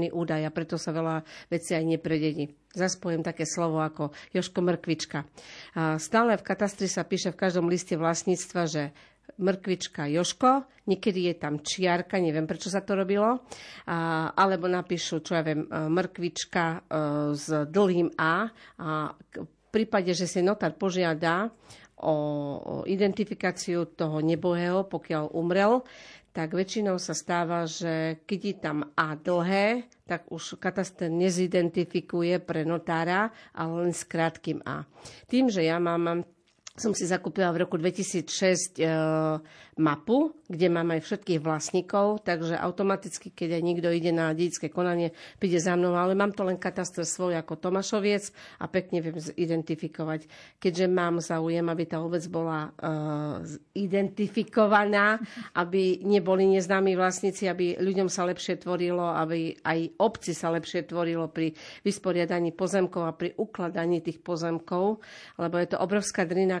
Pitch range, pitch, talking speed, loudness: 165-190 Hz, 175 Hz, 140 wpm, -28 LUFS